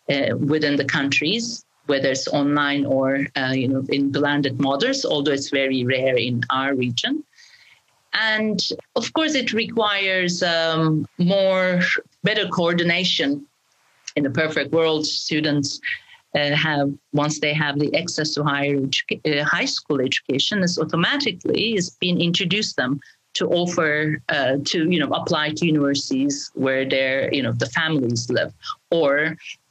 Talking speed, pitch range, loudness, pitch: 145 wpm, 140-185 Hz, -21 LUFS, 155 Hz